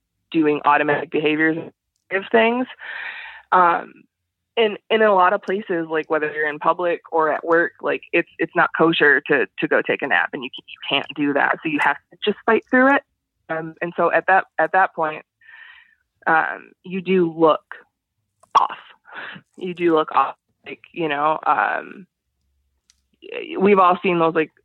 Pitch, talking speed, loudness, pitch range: 170 Hz, 180 wpm, -19 LUFS, 155-205 Hz